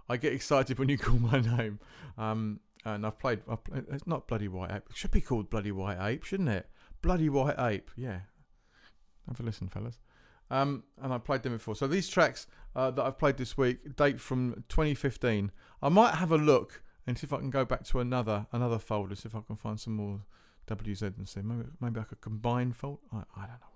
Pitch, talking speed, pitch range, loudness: 120 Hz, 225 wpm, 105-135 Hz, -32 LUFS